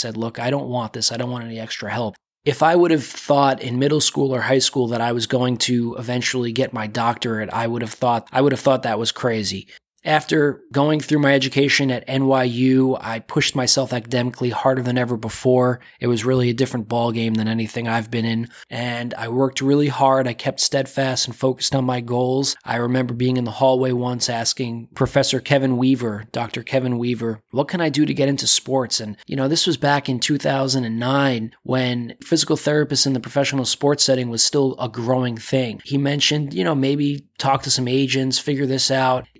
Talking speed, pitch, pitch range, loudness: 210 wpm, 130 Hz, 120-135 Hz, -19 LUFS